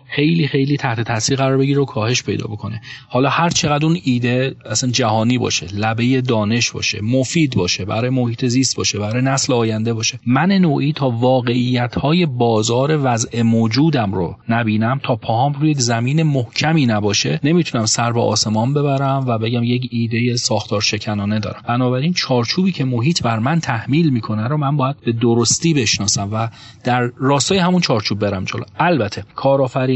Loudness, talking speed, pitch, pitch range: -17 LUFS, 160 wpm, 125 Hz, 115-135 Hz